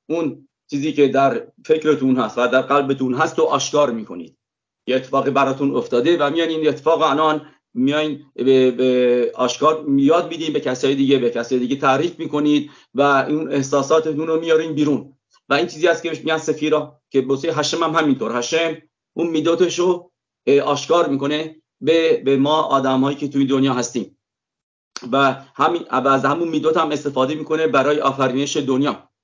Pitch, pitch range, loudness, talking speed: 145 Hz, 135-160 Hz, -18 LUFS, 160 wpm